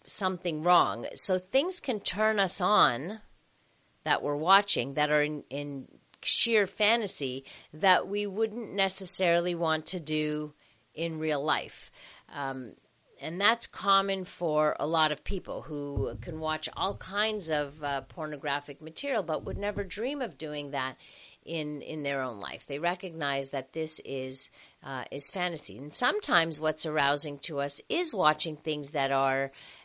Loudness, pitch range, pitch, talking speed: -30 LUFS, 145-190 Hz, 155 Hz, 155 wpm